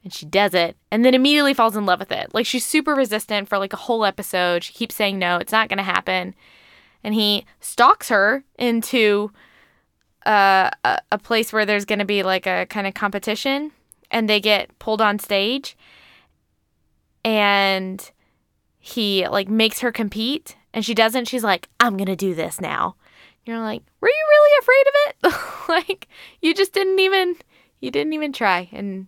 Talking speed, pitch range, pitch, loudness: 190 wpm, 200-255 Hz, 215 Hz, -19 LUFS